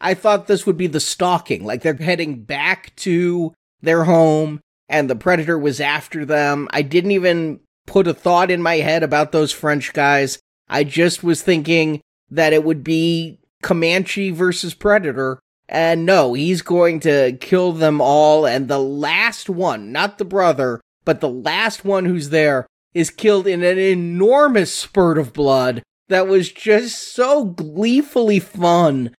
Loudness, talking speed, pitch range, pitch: -17 LUFS, 160 wpm, 150-185 Hz, 165 Hz